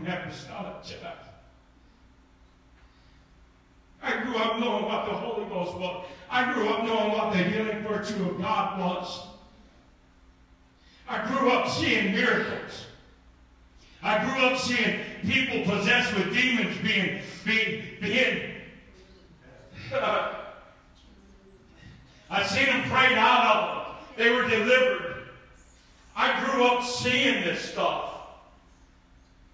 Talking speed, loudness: 110 wpm, -25 LUFS